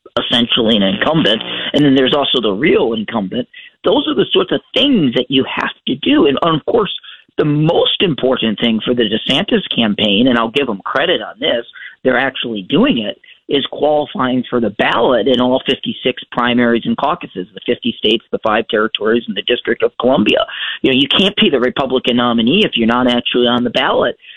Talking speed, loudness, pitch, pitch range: 195 wpm, -14 LUFS, 125 Hz, 120-150 Hz